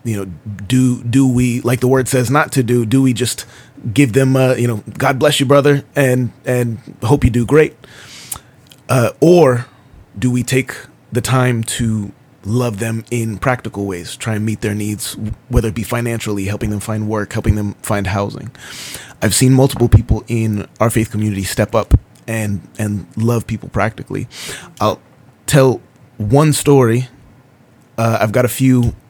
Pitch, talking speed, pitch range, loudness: 120 Hz, 175 wpm, 110-130 Hz, -15 LUFS